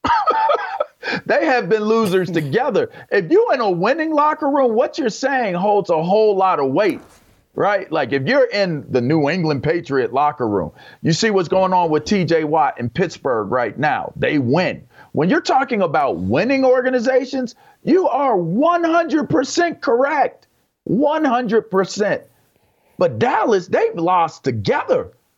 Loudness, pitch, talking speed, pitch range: -18 LUFS, 225 Hz, 145 wpm, 180-295 Hz